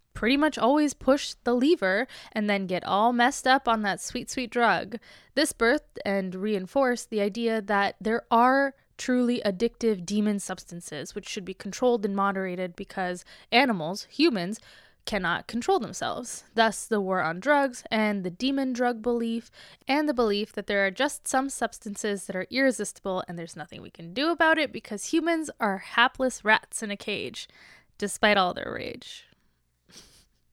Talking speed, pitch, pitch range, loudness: 165 wpm, 220 Hz, 195-255 Hz, -26 LUFS